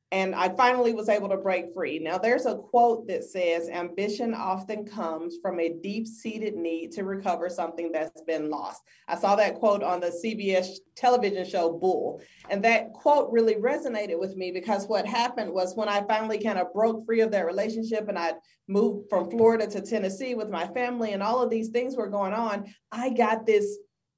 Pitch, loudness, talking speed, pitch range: 205 Hz, -27 LUFS, 200 wpm, 185-225 Hz